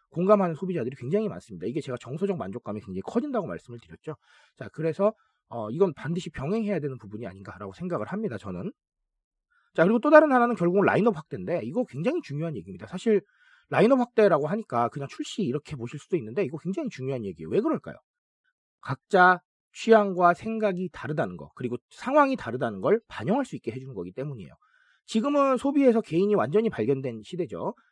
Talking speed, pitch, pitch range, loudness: 445 characters per minute, 180 Hz, 140-225 Hz, -26 LUFS